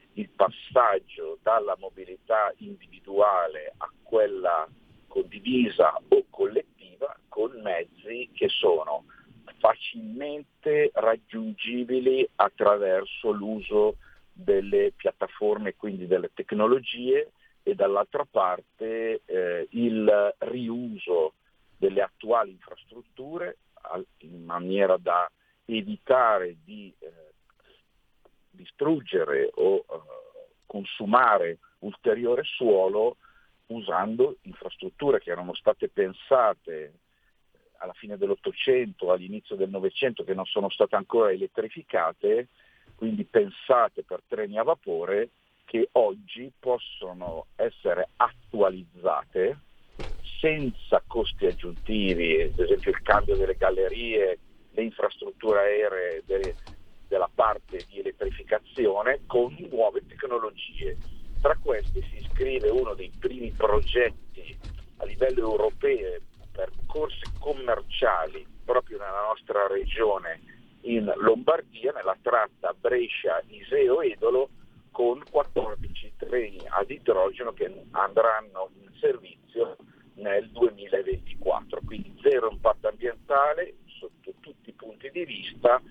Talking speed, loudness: 95 wpm, -26 LUFS